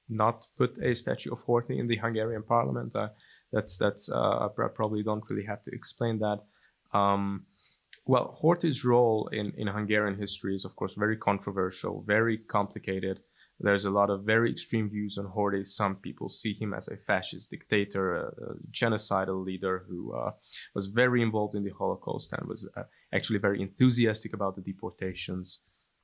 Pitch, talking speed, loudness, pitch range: 105 Hz, 175 wpm, -30 LUFS, 95-110 Hz